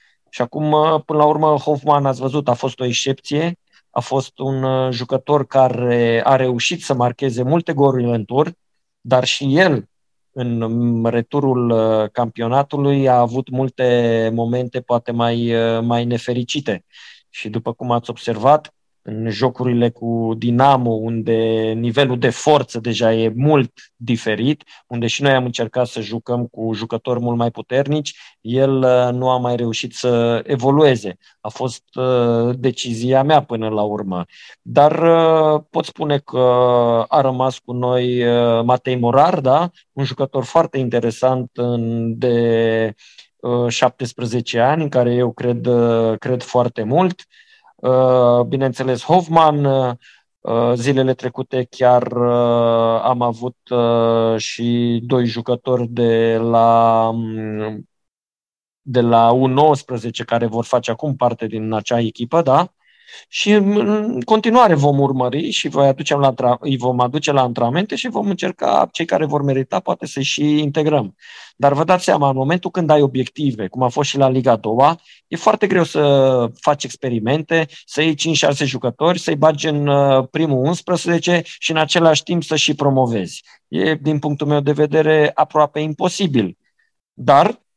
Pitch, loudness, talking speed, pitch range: 130 Hz, -17 LUFS, 135 wpm, 120-150 Hz